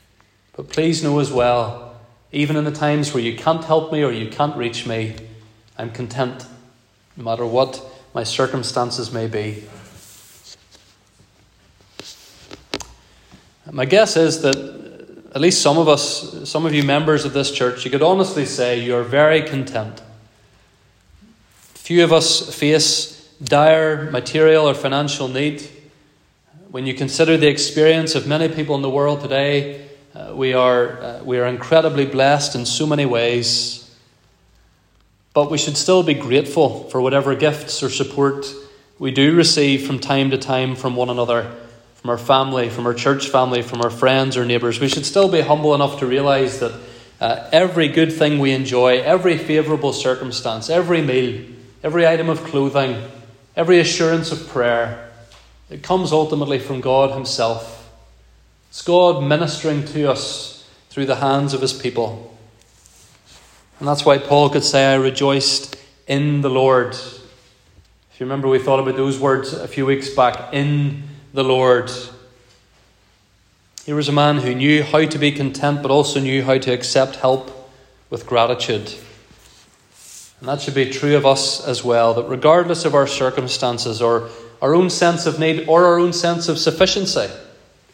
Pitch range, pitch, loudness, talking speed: 120-150 Hz, 135 Hz, -17 LUFS, 160 wpm